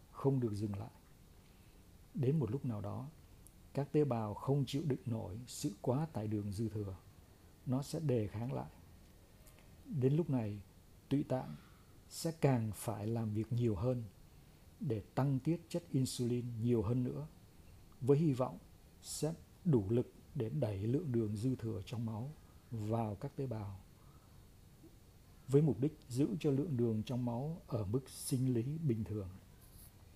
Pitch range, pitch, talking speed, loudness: 100-135 Hz, 115 Hz, 160 wpm, -38 LUFS